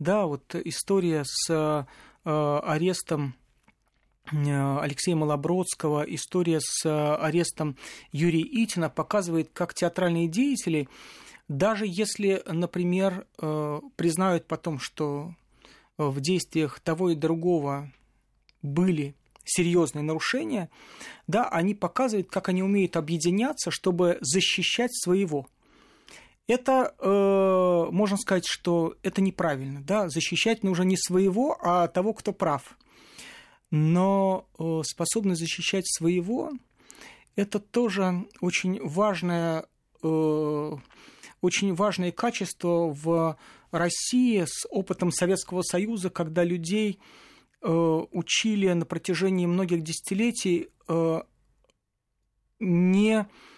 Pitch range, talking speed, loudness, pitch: 160-195 Hz, 95 wpm, -26 LUFS, 175 Hz